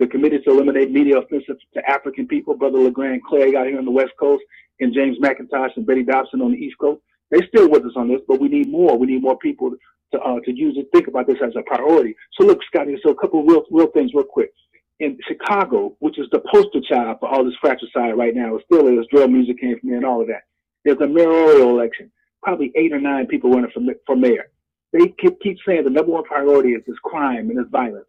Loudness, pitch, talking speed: -17 LUFS, 150 Hz, 250 wpm